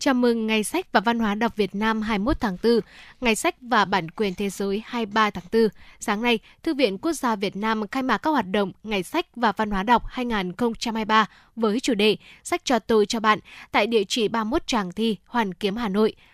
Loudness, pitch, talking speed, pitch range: -23 LUFS, 225 Hz, 225 wpm, 210-240 Hz